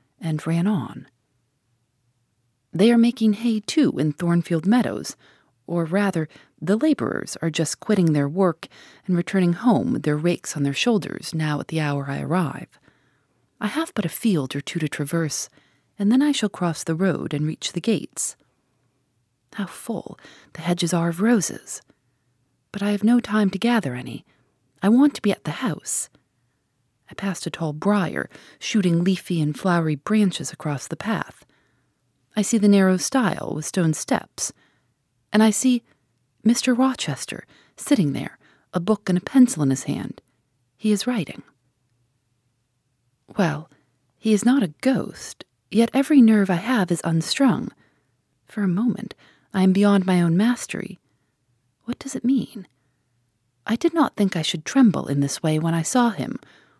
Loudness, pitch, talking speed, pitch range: -22 LUFS, 170 Hz, 165 wpm, 140-210 Hz